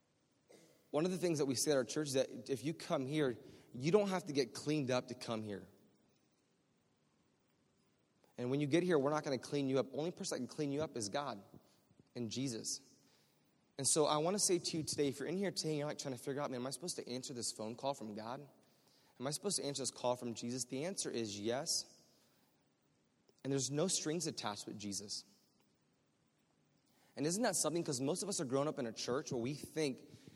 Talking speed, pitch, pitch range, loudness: 235 wpm, 140 Hz, 125-155 Hz, -39 LUFS